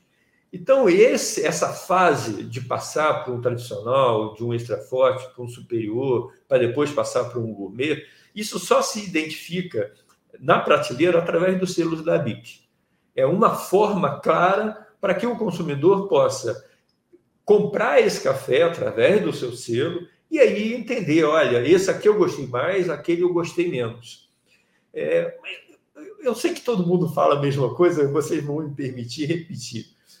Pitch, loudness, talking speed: 175 Hz, -21 LUFS, 155 wpm